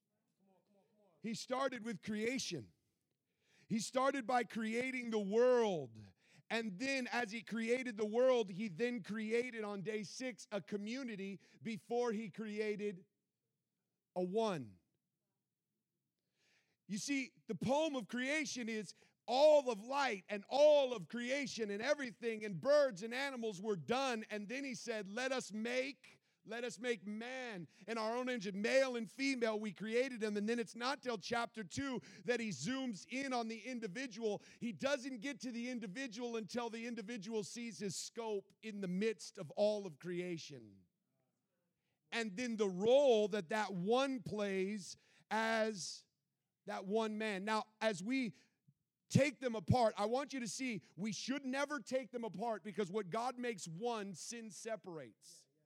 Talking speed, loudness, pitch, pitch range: 155 wpm, -39 LUFS, 225 Hz, 205-245 Hz